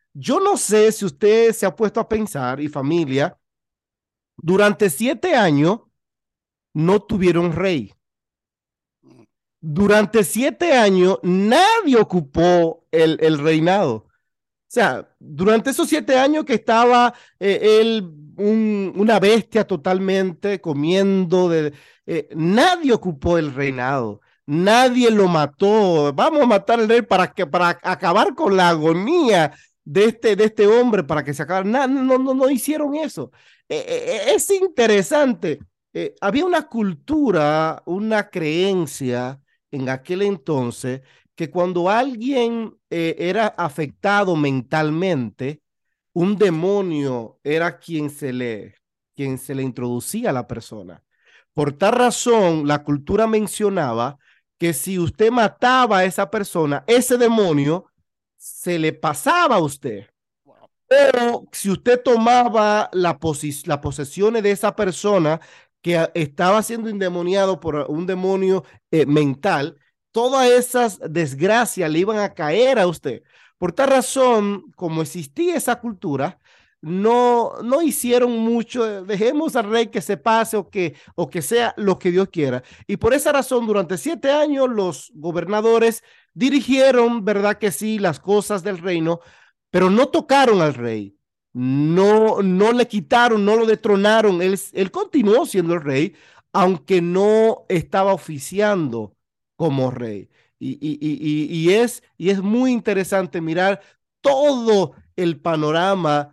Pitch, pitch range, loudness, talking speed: 195 Hz, 160-230 Hz, -18 LUFS, 135 wpm